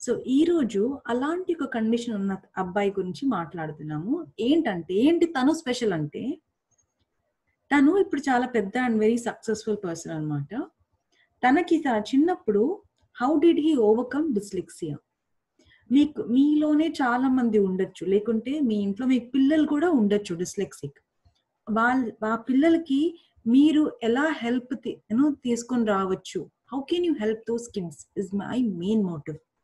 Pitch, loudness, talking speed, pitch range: 235 Hz, -25 LUFS, 125 wpm, 205-290 Hz